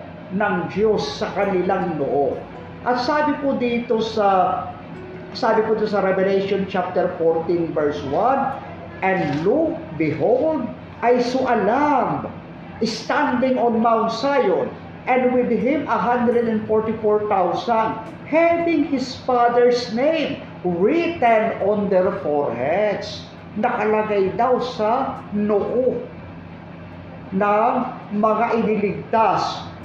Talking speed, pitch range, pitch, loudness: 100 wpm, 195-250 Hz, 225 Hz, -20 LUFS